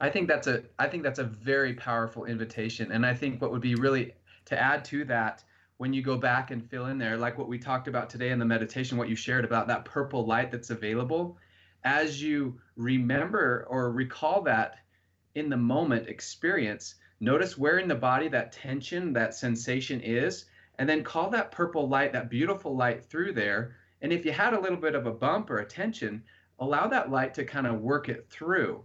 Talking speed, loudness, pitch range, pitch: 210 wpm, -29 LUFS, 115-140 Hz, 125 Hz